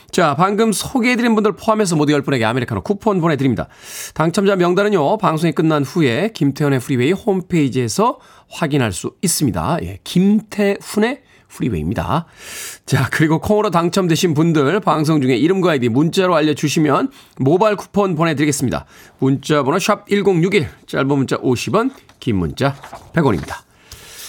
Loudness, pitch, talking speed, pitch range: -17 LUFS, 170 Hz, 350 characters per minute, 145-205 Hz